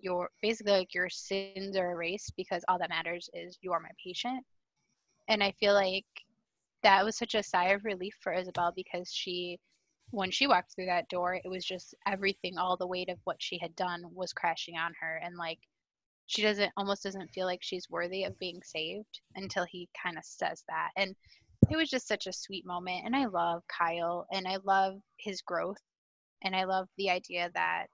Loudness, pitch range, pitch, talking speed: -33 LUFS, 175-195 Hz, 185 Hz, 200 wpm